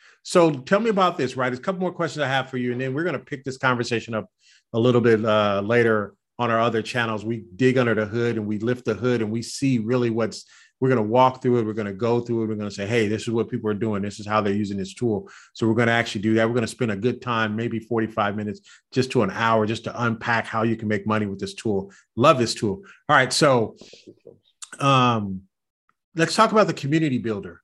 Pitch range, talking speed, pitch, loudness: 110-125 Hz, 265 wpm, 115 Hz, -22 LUFS